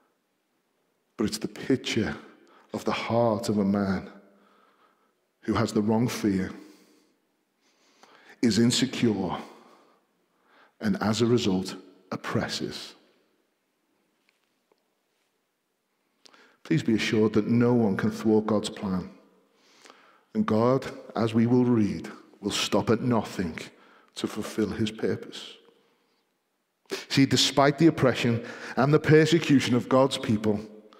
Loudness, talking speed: -25 LUFS, 110 wpm